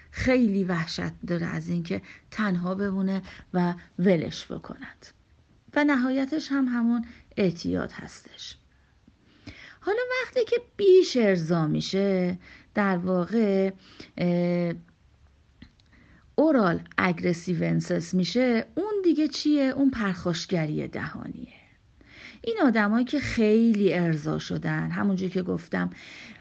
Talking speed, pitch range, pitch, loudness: 100 wpm, 175-250 Hz, 190 Hz, -26 LUFS